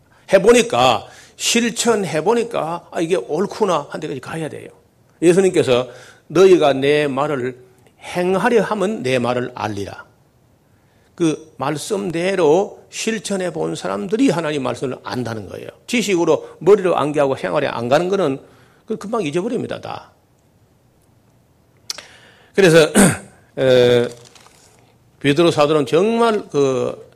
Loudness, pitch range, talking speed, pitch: -17 LUFS, 130-205 Hz, 250 characters per minute, 155 Hz